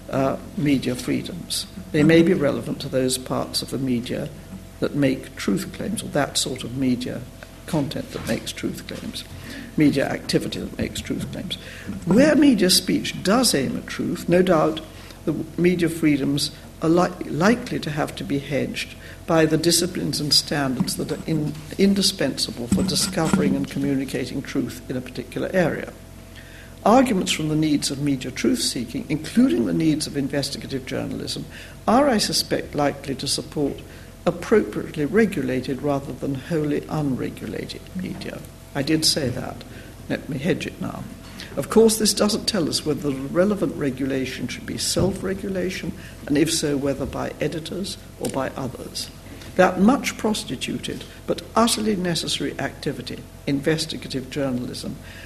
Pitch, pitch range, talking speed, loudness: 150 Hz, 135-180 Hz, 150 wpm, -23 LUFS